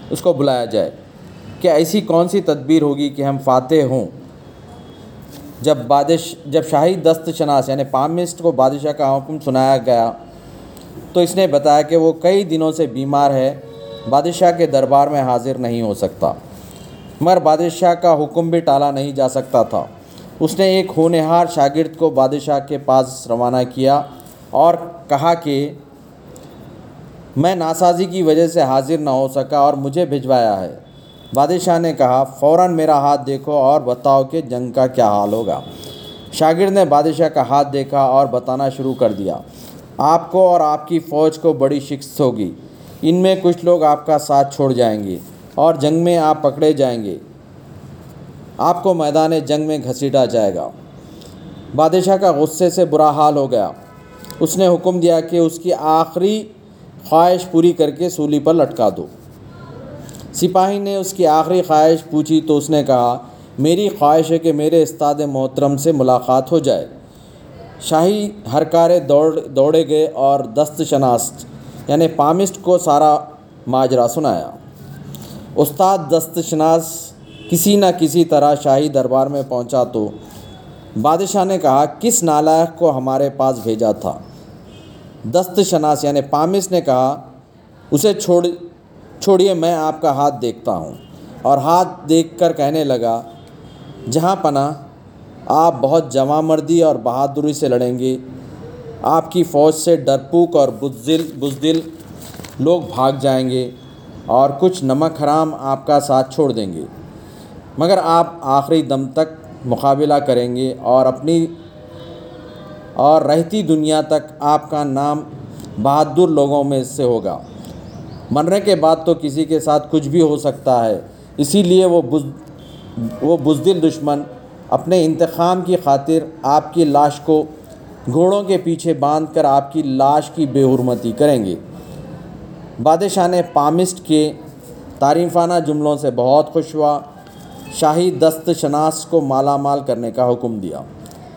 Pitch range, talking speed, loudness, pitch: 135-165 Hz, 155 wpm, -15 LUFS, 150 Hz